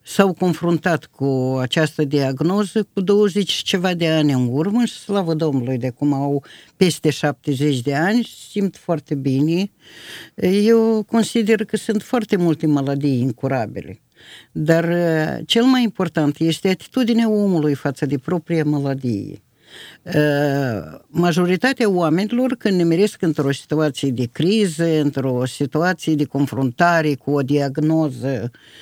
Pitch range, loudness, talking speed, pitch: 140-195 Hz, -19 LUFS, 125 wpm, 160 Hz